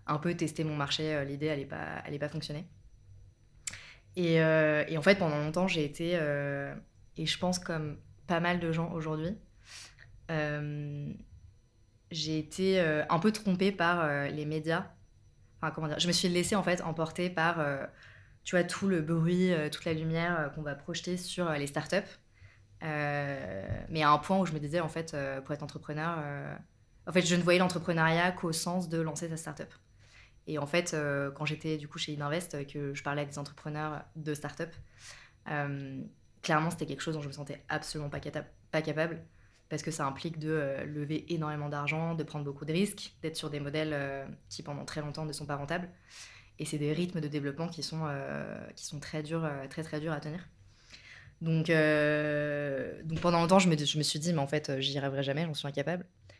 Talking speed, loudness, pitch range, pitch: 210 wpm, -33 LUFS, 140-165 Hz, 150 Hz